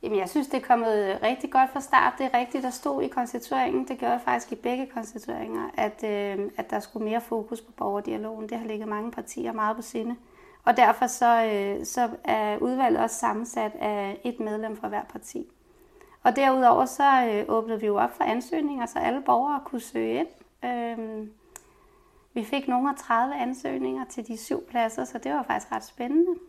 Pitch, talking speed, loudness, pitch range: 245 Hz, 200 wpm, -27 LUFS, 220-280 Hz